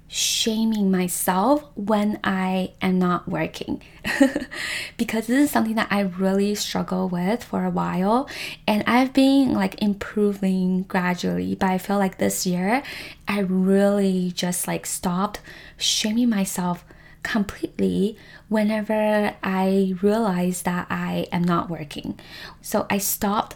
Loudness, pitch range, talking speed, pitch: -22 LUFS, 180-215 Hz, 125 wpm, 195 Hz